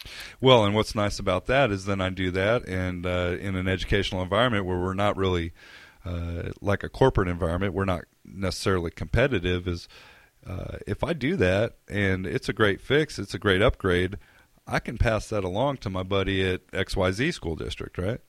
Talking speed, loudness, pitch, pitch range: 190 wpm, -26 LUFS, 95 Hz, 90-105 Hz